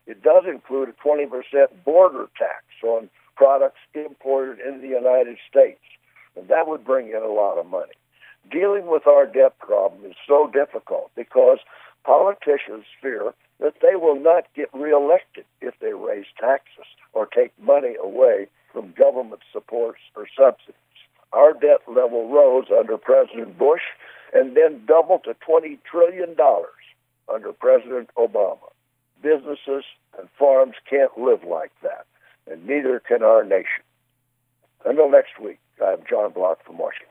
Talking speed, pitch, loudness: 140 wpm, 160 Hz, -19 LUFS